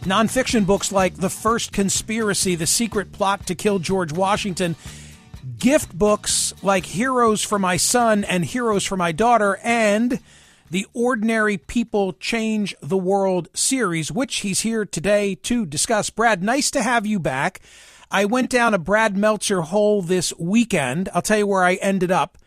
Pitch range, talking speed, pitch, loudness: 185-225 Hz, 165 wpm, 200 Hz, -20 LUFS